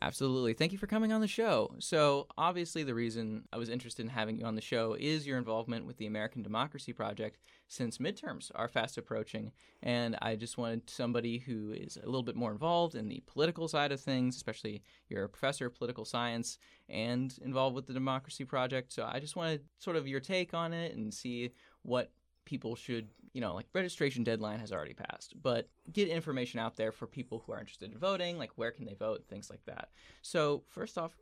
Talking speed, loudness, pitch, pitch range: 215 wpm, -37 LUFS, 125 Hz, 115-150 Hz